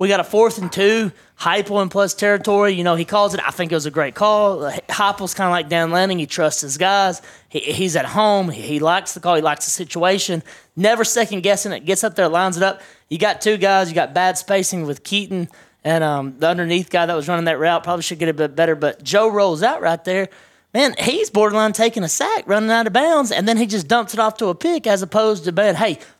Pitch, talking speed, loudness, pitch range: 190 Hz, 255 wpm, -18 LUFS, 170-210 Hz